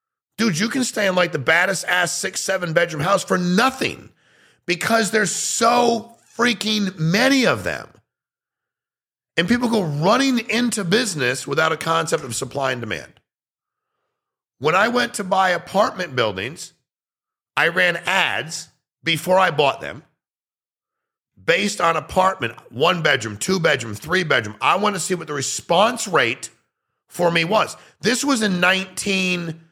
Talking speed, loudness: 150 wpm, -19 LUFS